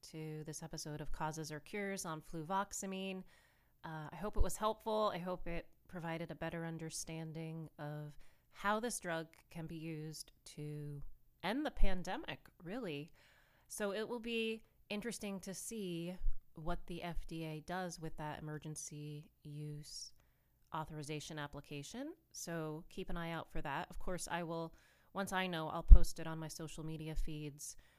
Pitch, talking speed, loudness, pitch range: 165 Hz, 155 wpm, -43 LUFS, 155-185 Hz